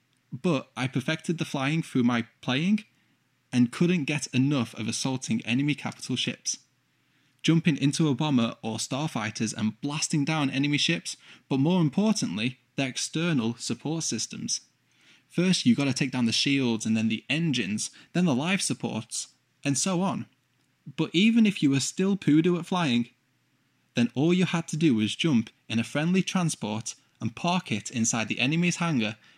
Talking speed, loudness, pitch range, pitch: 165 wpm, -27 LUFS, 120-165 Hz, 140 Hz